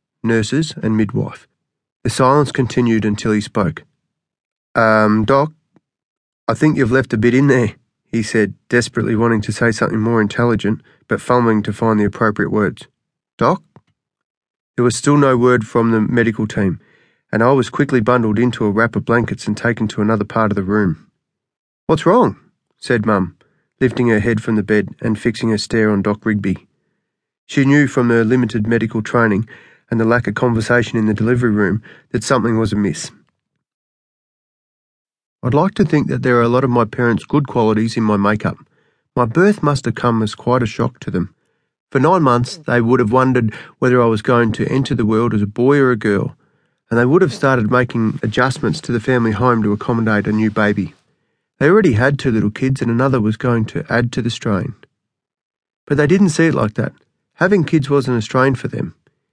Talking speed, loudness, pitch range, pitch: 195 wpm, -16 LUFS, 110-130 Hz, 115 Hz